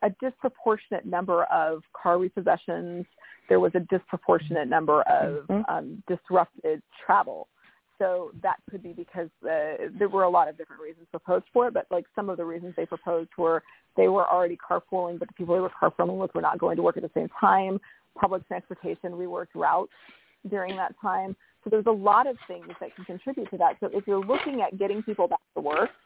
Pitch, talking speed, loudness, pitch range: 185 Hz, 205 wpm, -26 LUFS, 175-205 Hz